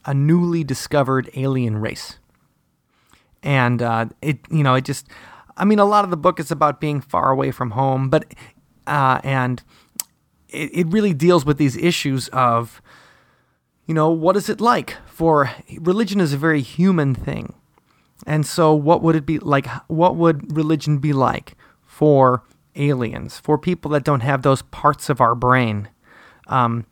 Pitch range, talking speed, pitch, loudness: 130-165 Hz, 165 wpm, 145 Hz, -19 LUFS